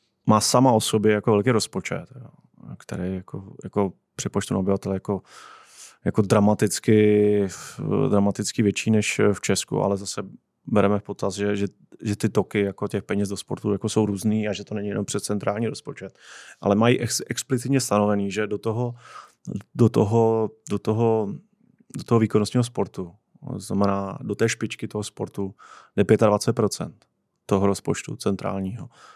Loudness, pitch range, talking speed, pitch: -23 LUFS, 100-110 Hz, 150 wpm, 105 Hz